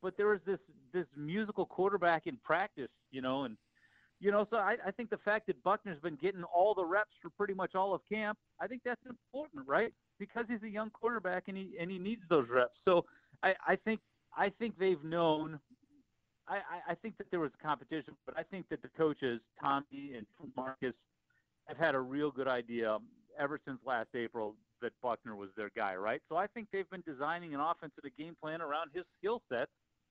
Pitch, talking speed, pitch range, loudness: 180 Hz, 205 wpm, 150-210 Hz, -37 LUFS